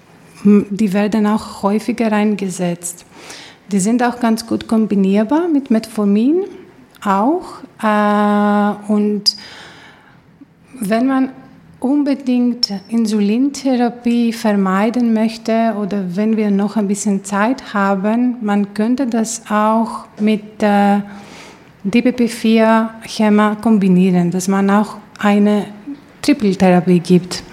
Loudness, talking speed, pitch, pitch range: -15 LUFS, 90 wpm, 215 Hz, 205-230 Hz